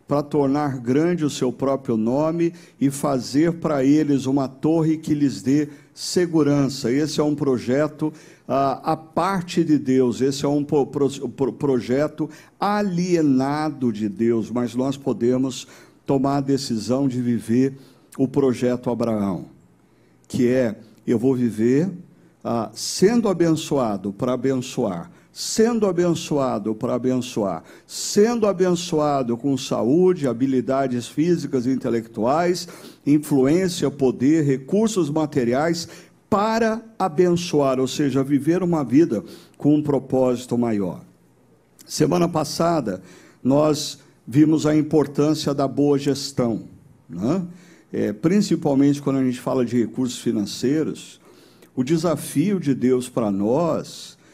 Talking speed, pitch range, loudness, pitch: 120 wpm, 125-155 Hz, -21 LUFS, 140 Hz